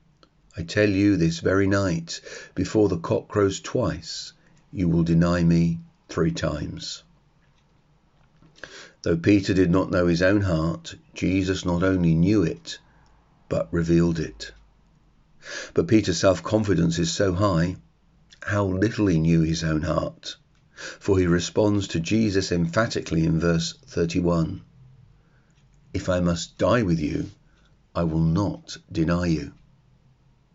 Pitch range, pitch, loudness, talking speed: 85-105 Hz, 95 Hz, -23 LUFS, 130 wpm